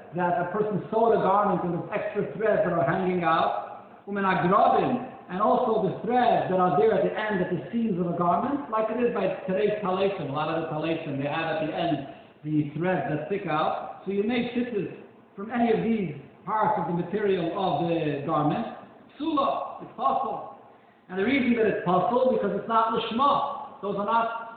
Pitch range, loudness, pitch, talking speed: 175-225 Hz, -26 LUFS, 200 Hz, 210 wpm